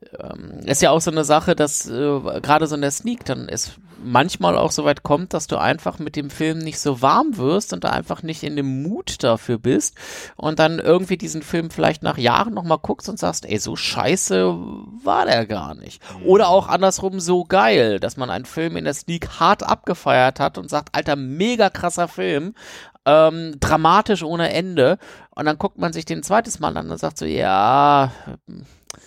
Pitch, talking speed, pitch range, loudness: 150 Hz, 200 wpm, 135-170 Hz, -19 LUFS